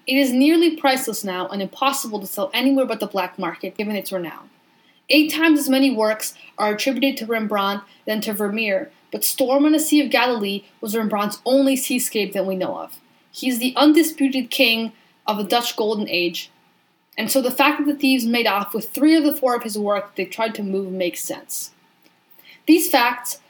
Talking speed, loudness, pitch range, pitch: 200 wpm, -20 LUFS, 205-270 Hz, 230 Hz